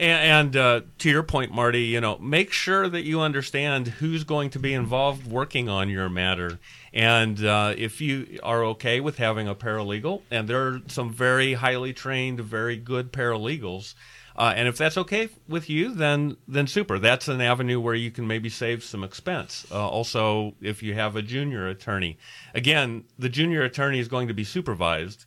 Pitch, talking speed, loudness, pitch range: 120 Hz, 190 wpm, -24 LUFS, 110-140 Hz